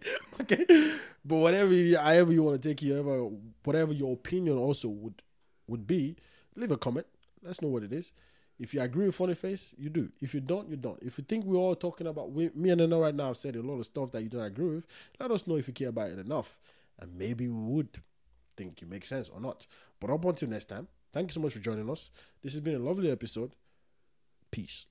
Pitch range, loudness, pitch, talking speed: 120-170 Hz, -31 LUFS, 145 Hz, 240 wpm